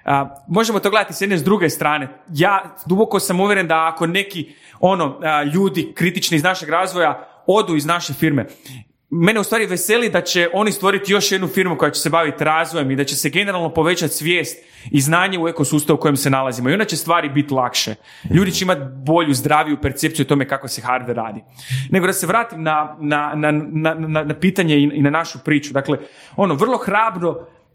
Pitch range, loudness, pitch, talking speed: 145-185 Hz, -18 LUFS, 160 Hz, 210 wpm